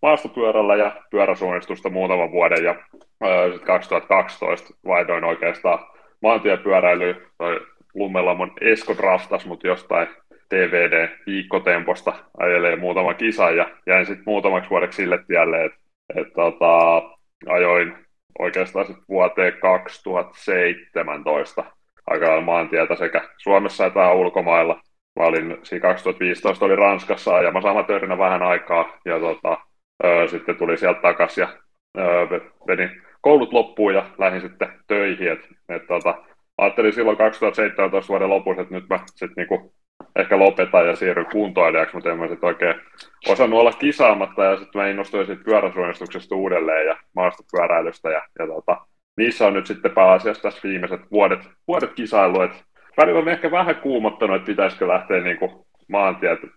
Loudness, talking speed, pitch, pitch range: -19 LUFS, 130 wpm, 95 Hz, 90-105 Hz